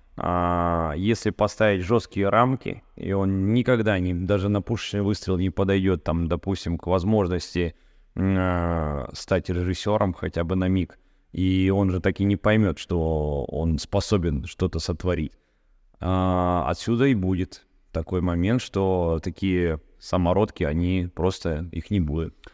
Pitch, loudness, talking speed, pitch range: 90 Hz, -24 LUFS, 140 wpm, 85-100 Hz